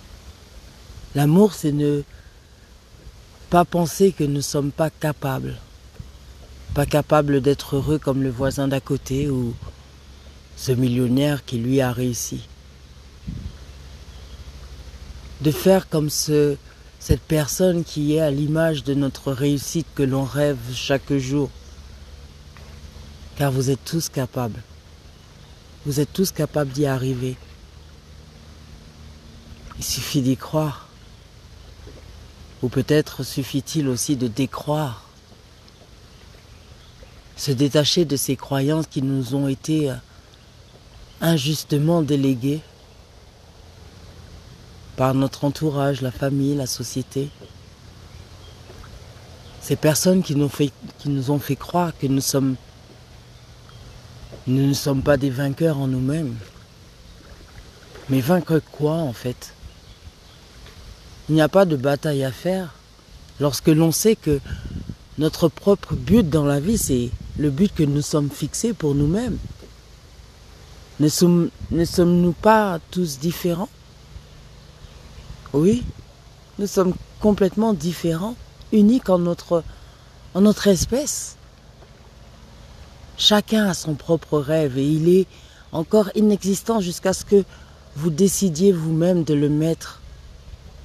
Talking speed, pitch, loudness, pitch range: 115 wpm, 135 Hz, -21 LUFS, 95-155 Hz